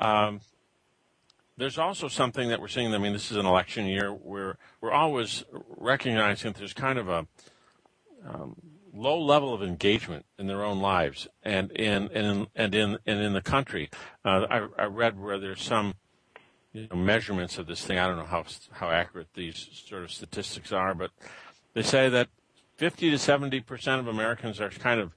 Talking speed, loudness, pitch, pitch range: 190 wpm, -28 LUFS, 105 Hz, 100-125 Hz